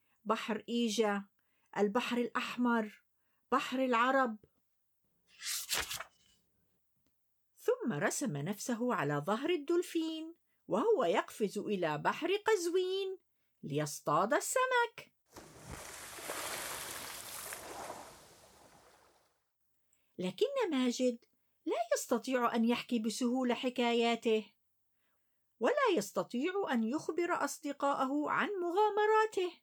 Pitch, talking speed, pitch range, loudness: 250 Hz, 70 wpm, 230-345 Hz, -34 LUFS